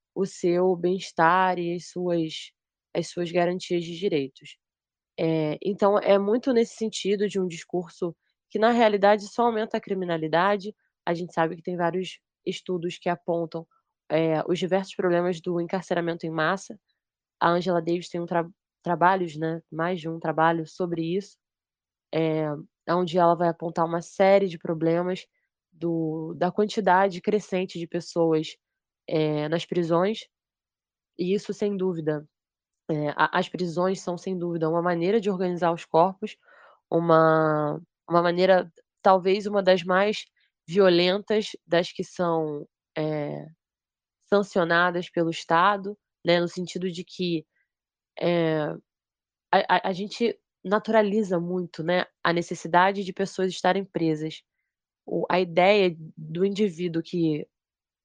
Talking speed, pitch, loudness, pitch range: 135 wpm, 175 Hz, -25 LUFS, 165-190 Hz